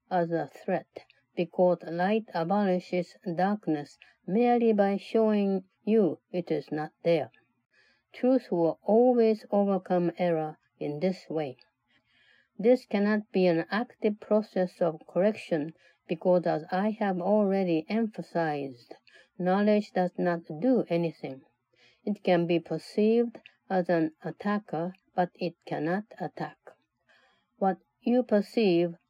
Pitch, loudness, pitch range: 180 Hz, -28 LUFS, 170-210 Hz